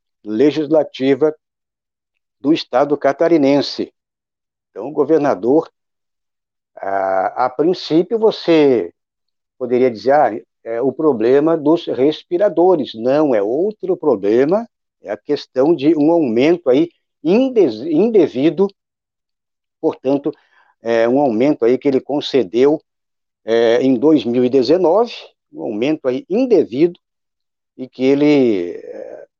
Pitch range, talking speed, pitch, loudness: 130-200 Hz, 105 wpm, 150 Hz, -16 LUFS